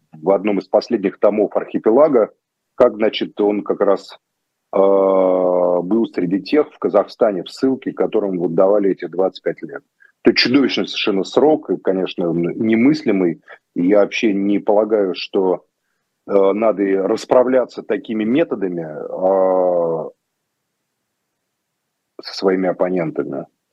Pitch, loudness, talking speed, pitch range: 95 Hz, -17 LUFS, 120 wpm, 90-110 Hz